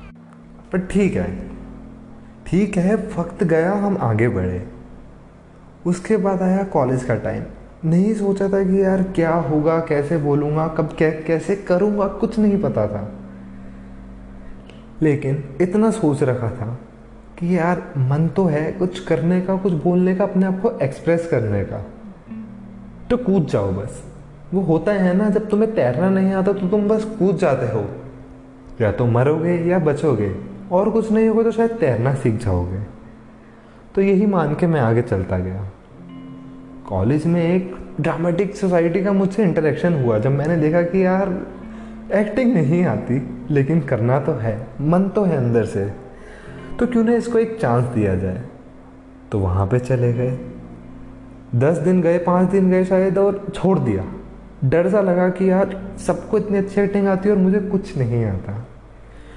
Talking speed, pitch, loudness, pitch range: 160 wpm, 165 Hz, -19 LUFS, 115-195 Hz